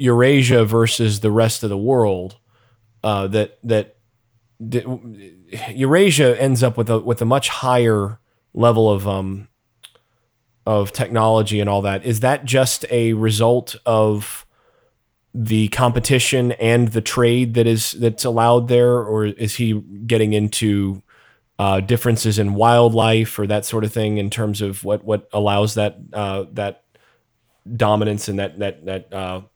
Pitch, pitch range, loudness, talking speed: 110 Hz, 105-120 Hz, -18 LUFS, 150 wpm